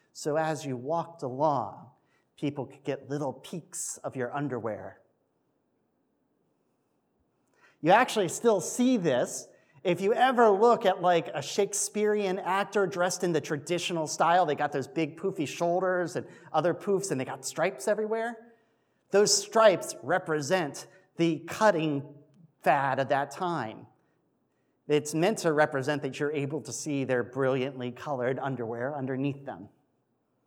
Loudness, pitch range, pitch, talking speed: -28 LUFS, 140-190 Hz, 160 Hz, 140 wpm